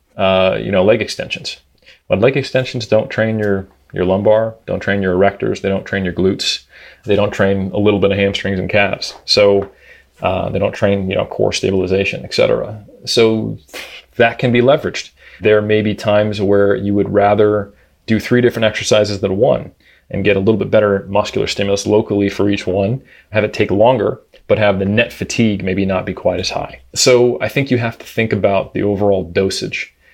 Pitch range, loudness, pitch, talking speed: 100-110 Hz, -15 LUFS, 100 Hz, 195 wpm